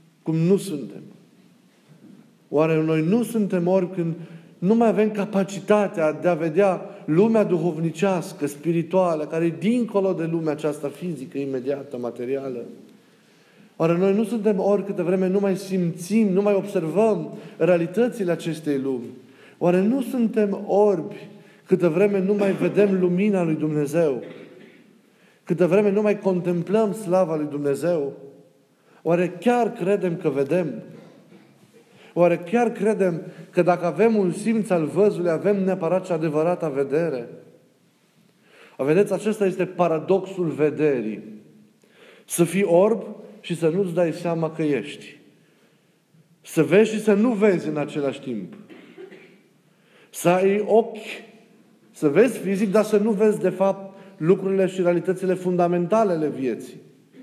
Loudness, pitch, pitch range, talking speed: -22 LUFS, 185 Hz, 165-205 Hz, 135 wpm